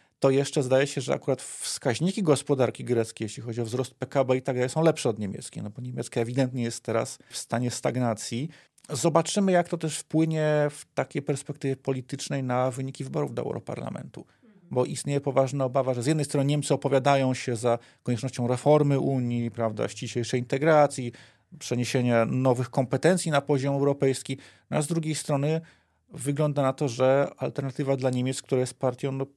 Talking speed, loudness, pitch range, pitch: 170 wpm, -27 LUFS, 125-145 Hz, 135 Hz